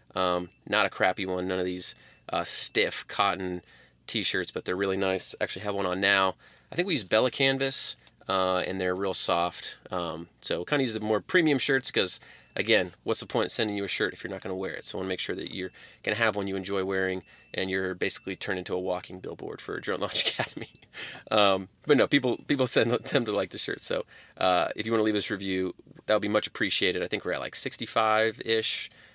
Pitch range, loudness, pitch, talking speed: 95-110 Hz, -27 LUFS, 95 Hz, 245 wpm